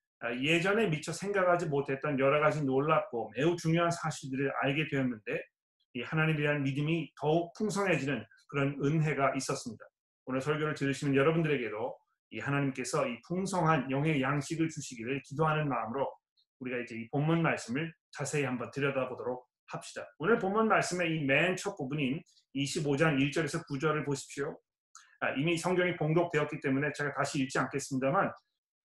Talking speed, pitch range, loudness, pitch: 370 characters per minute, 135-165 Hz, -32 LUFS, 145 Hz